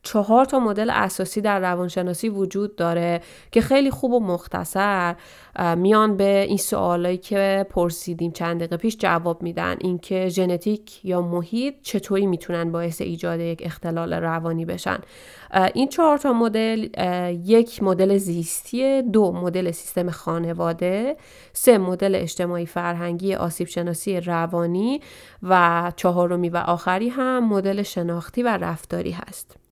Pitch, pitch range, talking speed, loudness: 185 Hz, 175-210 Hz, 130 wpm, -22 LUFS